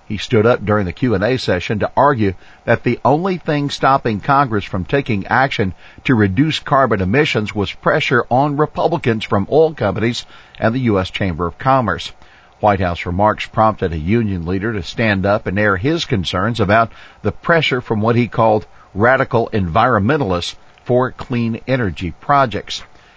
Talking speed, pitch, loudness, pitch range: 160 wpm, 110 Hz, -16 LUFS, 100-130 Hz